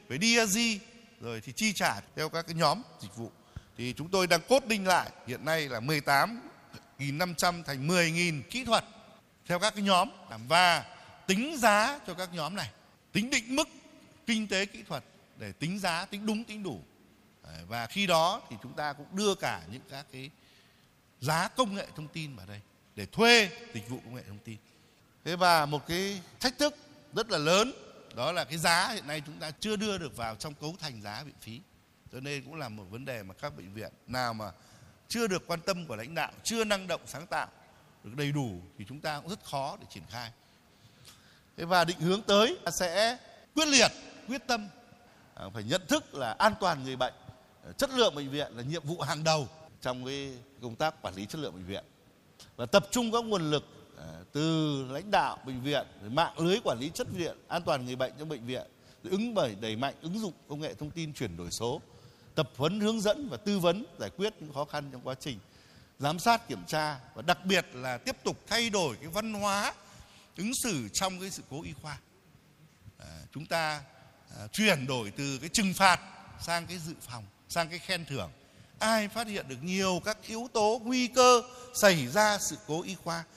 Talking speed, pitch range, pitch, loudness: 210 wpm, 130-200 Hz, 160 Hz, -30 LUFS